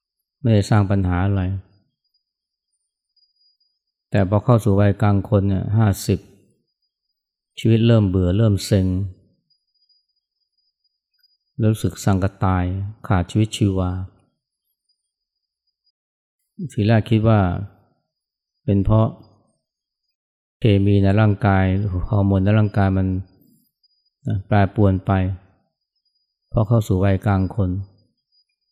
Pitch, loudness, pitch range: 100 Hz, -19 LUFS, 95-110 Hz